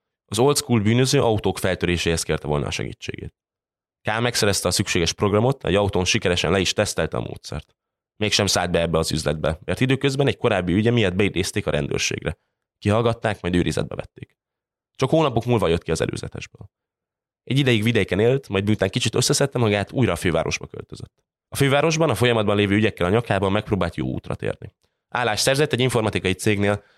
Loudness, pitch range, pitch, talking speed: -21 LUFS, 90-120 Hz, 105 Hz, 175 wpm